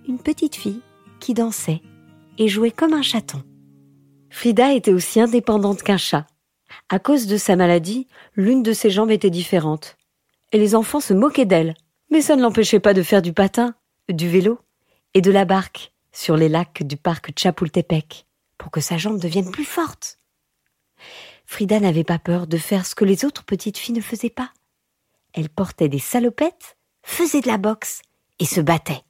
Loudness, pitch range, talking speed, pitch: -19 LUFS, 170-235 Hz, 180 wpm, 200 Hz